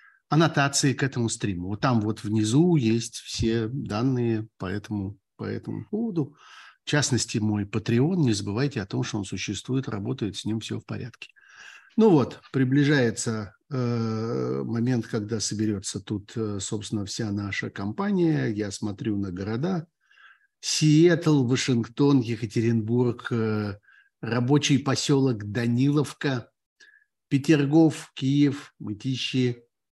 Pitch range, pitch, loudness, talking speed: 110-145 Hz, 120 Hz, -25 LUFS, 120 wpm